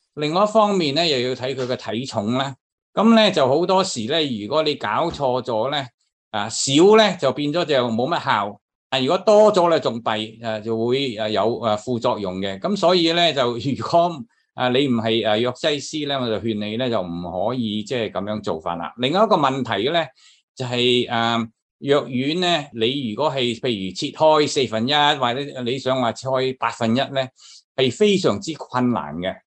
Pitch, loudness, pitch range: 130 Hz, -20 LUFS, 115-150 Hz